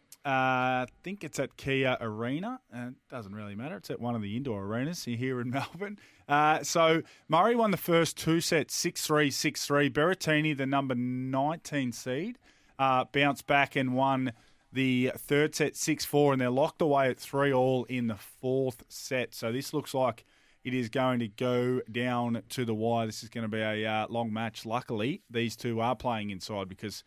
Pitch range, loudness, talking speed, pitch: 115-145 Hz, -30 LUFS, 190 wpm, 130 Hz